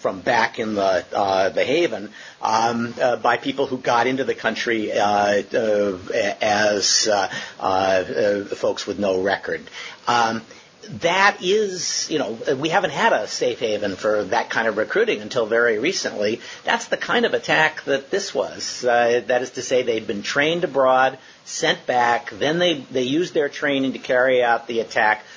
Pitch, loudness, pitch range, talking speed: 125 Hz, -20 LUFS, 115-155 Hz, 175 wpm